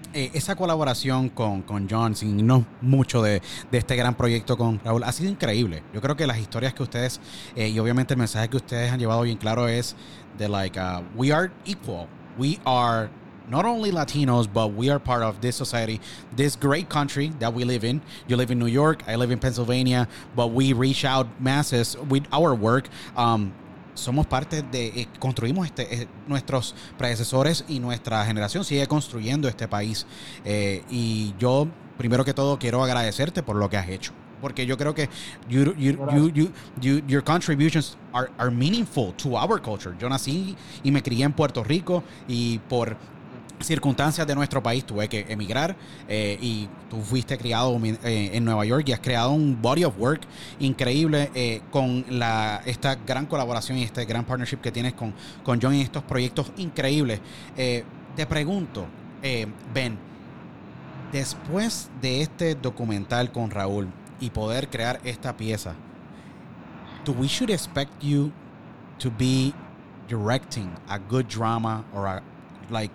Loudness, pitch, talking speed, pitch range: -25 LUFS, 125 Hz, 175 wpm, 115-140 Hz